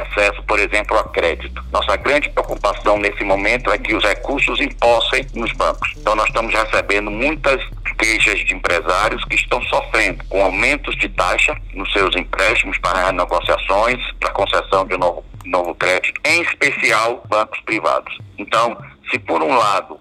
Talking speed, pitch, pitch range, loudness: 155 wpm, 105 Hz, 100-110 Hz, -17 LUFS